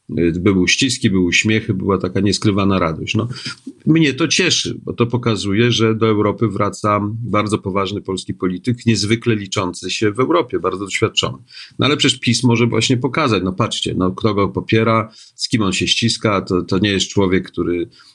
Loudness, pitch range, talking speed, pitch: -17 LUFS, 95-115 Hz, 180 wpm, 105 Hz